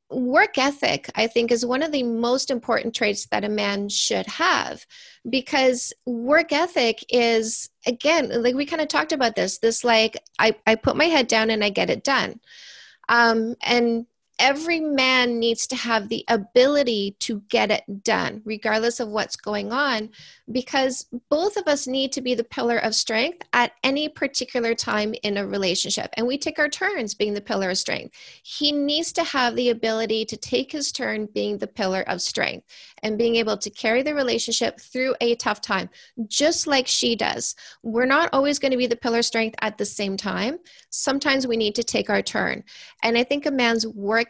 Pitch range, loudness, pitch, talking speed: 220-270 Hz, -22 LUFS, 235 Hz, 195 wpm